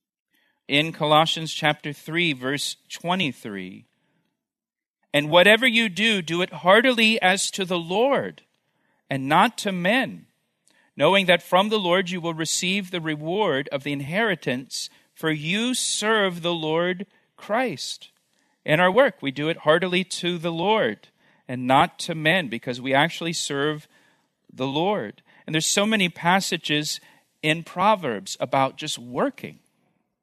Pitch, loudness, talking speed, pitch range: 175 Hz, -22 LUFS, 140 wpm, 150-200 Hz